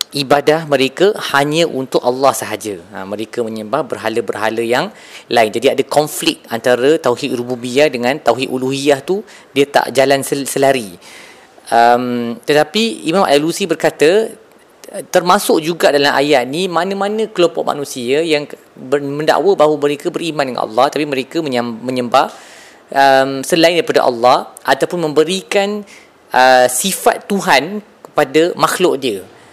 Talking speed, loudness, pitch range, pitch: 125 wpm, -14 LUFS, 125-170 Hz, 145 Hz